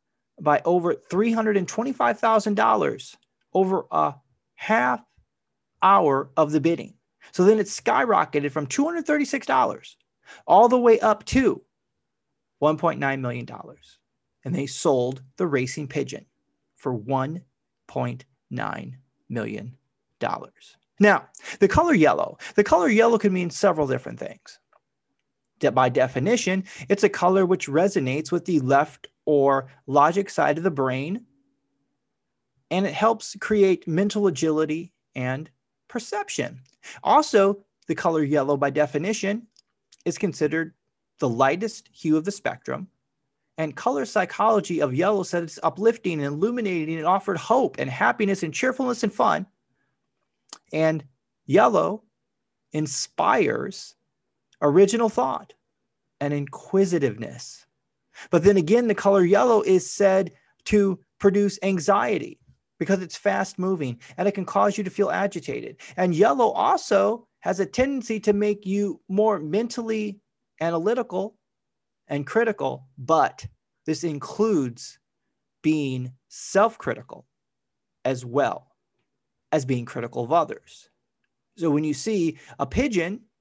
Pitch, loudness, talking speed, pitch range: 180 Hz, -23 LUFS, 120 wpm, 145-210 Hz